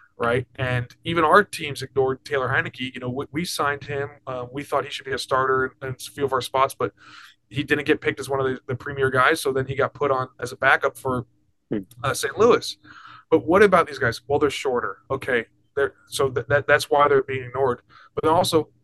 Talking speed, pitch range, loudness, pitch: 240 wpm, 130-145 Hz, -23 LUFS, 135 Hz